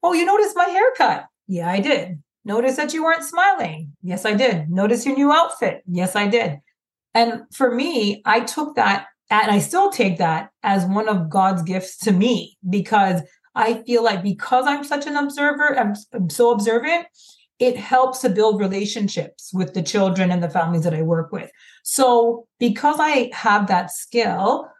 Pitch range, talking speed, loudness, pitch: 185-260 Hz, 180 wpm, -19 LUFS, 220 Hz